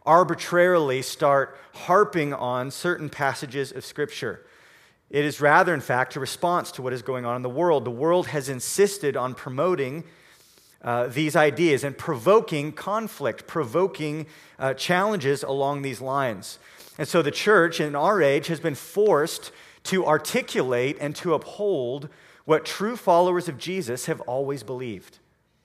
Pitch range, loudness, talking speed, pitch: 135-175 Hz, -24 LUFS, 150 wpm, 150 Hz